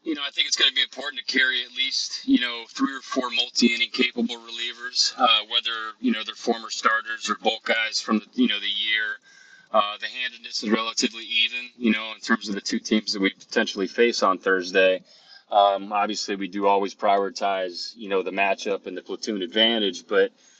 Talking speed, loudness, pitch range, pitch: 210 wpm, -23 LUFS, 100-125 Hz, 115 Hz